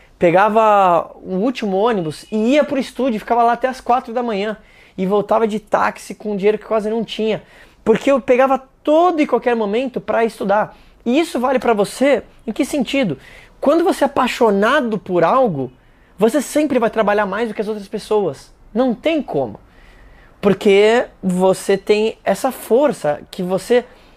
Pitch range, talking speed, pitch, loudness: 200-255 Hz, 175 wpm, 220 Hz, -17 LUFS